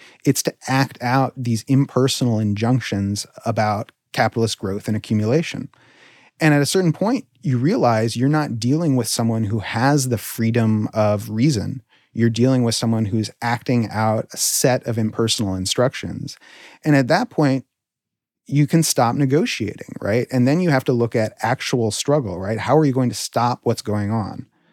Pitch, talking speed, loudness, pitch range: 120 Hz, 170 wpm, -20 LUFS, 110-135 Hz